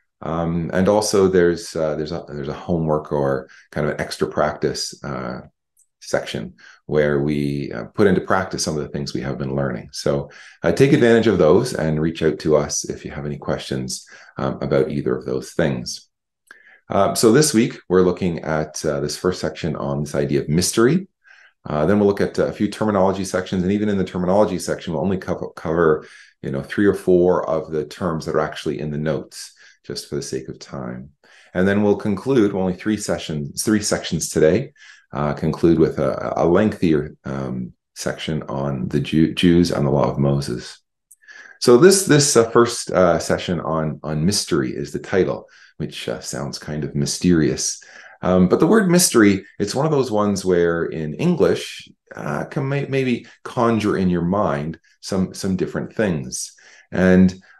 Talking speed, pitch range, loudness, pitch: 190 wpm, 75-100 Hz, -20 LUFS, 85 Hz